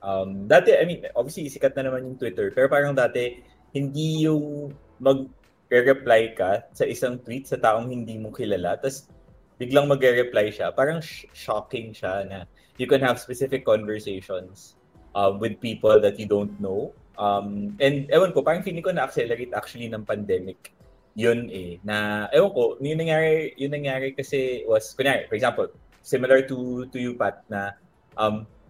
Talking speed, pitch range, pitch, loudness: 160 wpm, 105-140 Hz, 125 Hz, -24 LUFS